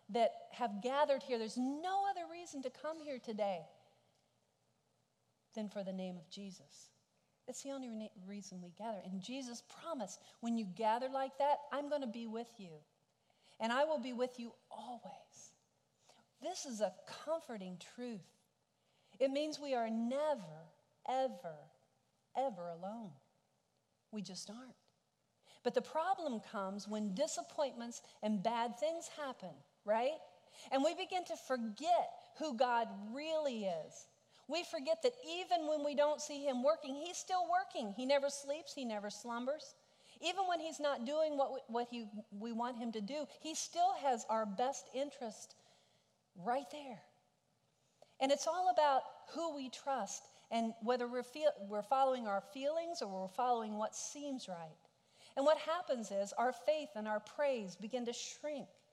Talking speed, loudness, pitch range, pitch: 160 wpm, -40 LUFS, 215-295 Hz, 255 Hz